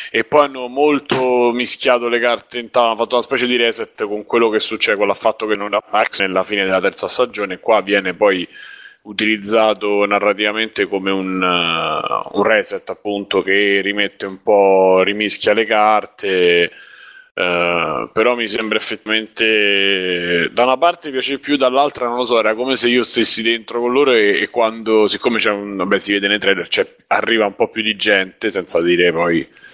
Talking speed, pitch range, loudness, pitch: 180 wpm, 100-120 Hz, -16 LUFS, 110 Hz